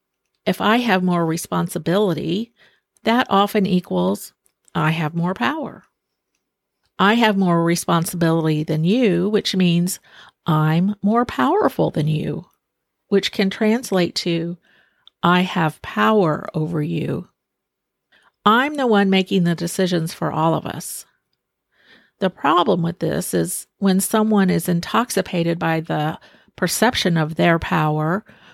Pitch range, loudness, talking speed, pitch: 165-200 Hz, -19 LUFS, 125 wpm, 180 Hz